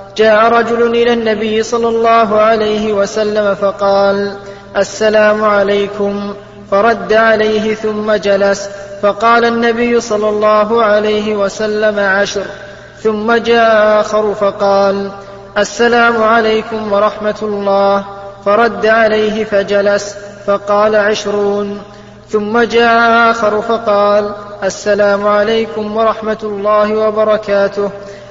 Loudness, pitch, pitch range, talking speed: -12 LUFS, 210 Hz, 200-220 Hz, 95 wpm